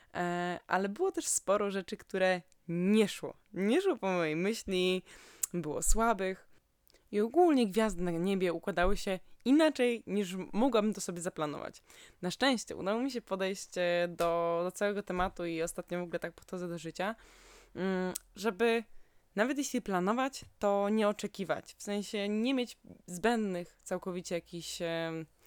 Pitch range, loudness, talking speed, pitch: 175-215 Hz, -33 LUFS, 140 wpm, 190 Hz